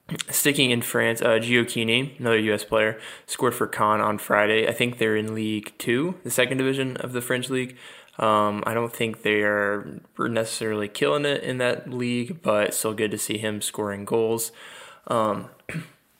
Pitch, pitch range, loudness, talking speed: 115 Hz, 110-125 Hz, -24 LUFS, 175 wpm